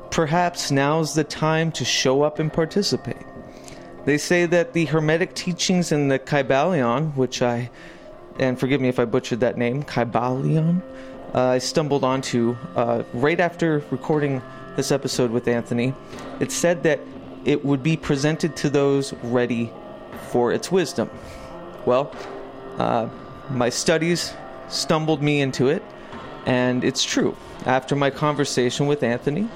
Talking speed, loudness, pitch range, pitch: 140 wpm, -22 LUFS, 125-160 Hz, 140 Hz